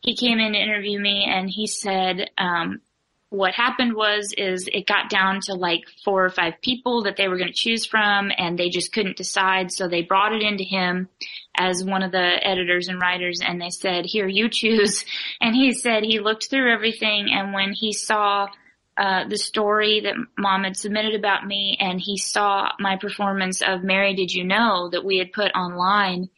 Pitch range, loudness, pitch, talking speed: 185-215 Hz, -21 LUFS, 200 Hz, 200 wpm